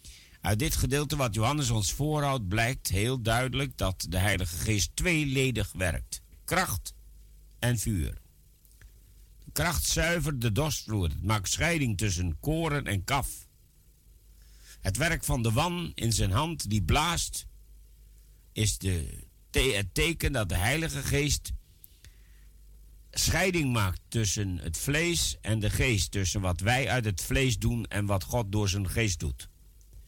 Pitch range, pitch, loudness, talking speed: 90-130 Hz, 105 Hz, -29 LUFS, 140 wpm